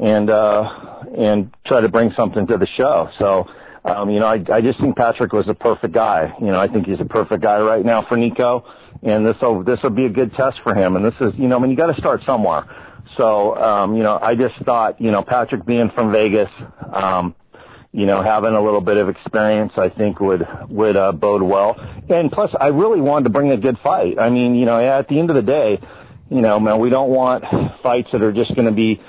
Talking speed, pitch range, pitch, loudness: 250 wpm, 105-125 Hz, 110 Hz, -16 LUFS